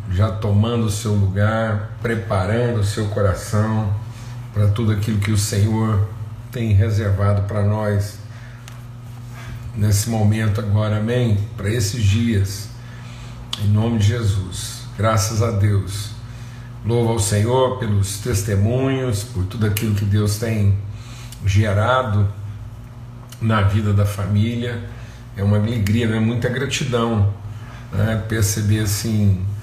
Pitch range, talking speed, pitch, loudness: 105-115 Hz, 120 wpm, 110 Hz, -20 LUFS